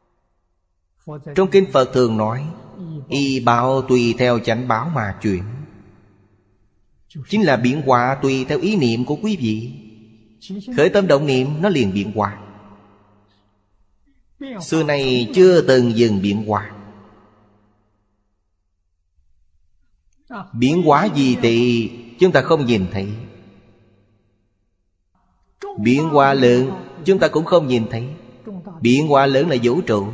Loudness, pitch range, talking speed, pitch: -17 LUFS, 105-140 Hz, 125 wpm, 115 Hz